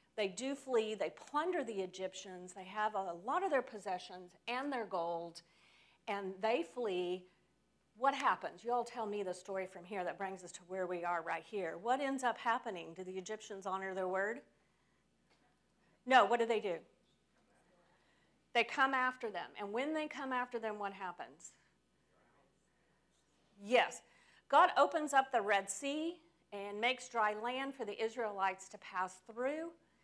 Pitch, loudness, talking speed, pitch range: 210 Hz, -38 LUFS, 165 wpm, 185-250 Hz